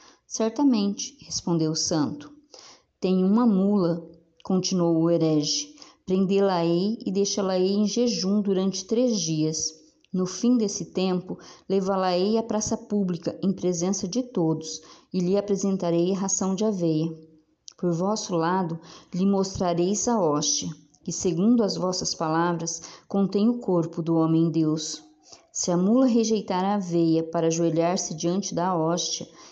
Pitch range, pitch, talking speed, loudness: 165-200 Hz, 185 Hz, 135 wpm, -25 LUFS